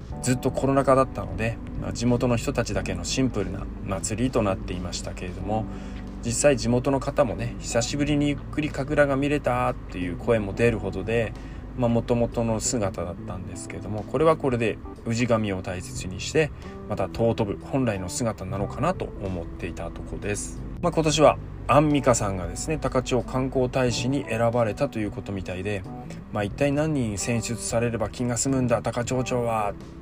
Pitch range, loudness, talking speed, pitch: 100-130 Hz, -25 LUFS, 375 characters per minute, 115 Hz